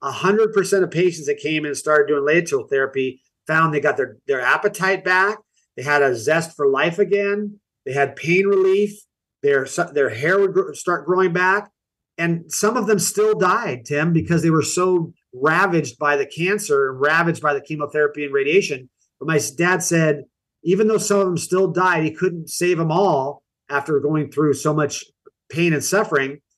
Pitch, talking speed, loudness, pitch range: 170 Hz, 185 wpm, -19 LUFS, 145-195 Hz